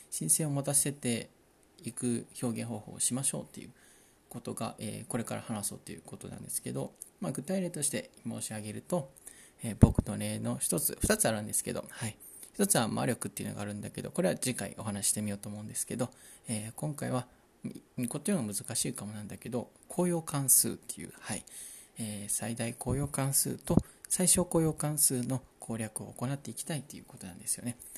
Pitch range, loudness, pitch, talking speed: 110-140 Hz, -32 LUFS, 120 Hz, 365 characters per minute